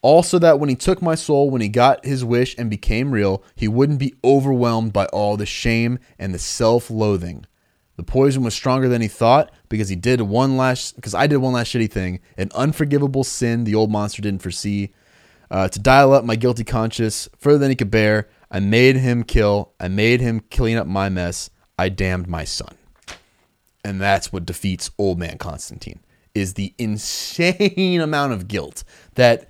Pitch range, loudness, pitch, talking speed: 100-130 Hz, -19 LUFS, 115 Hz, 190 wpm